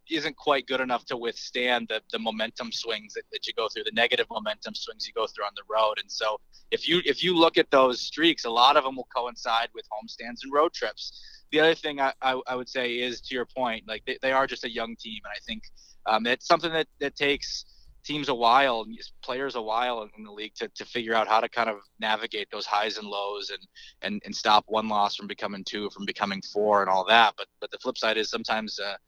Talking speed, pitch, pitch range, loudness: 250 wpm, 125 Hz, 110-155 Hz, -26 LUFS